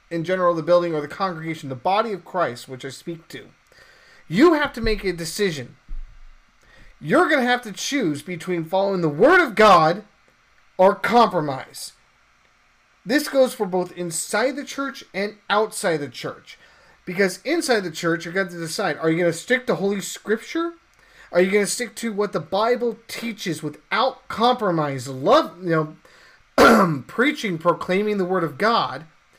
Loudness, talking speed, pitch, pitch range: -21 LUFS, 175 wpm, 190 Hz, 165-230 Hz